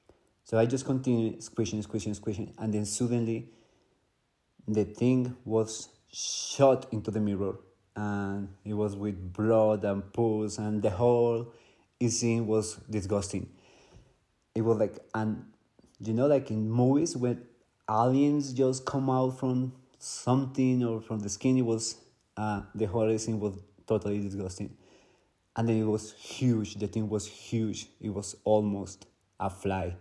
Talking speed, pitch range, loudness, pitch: 145 wpm, 105-120 Hz, -30 LUFS, 110 Hz